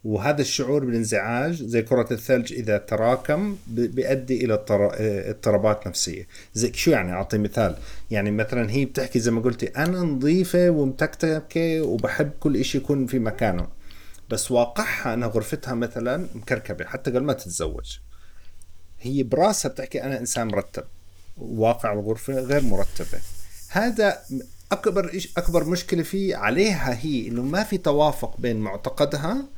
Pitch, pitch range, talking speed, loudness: 120 Hz, 105-145 Hz, 135 wpm, -24 LUFS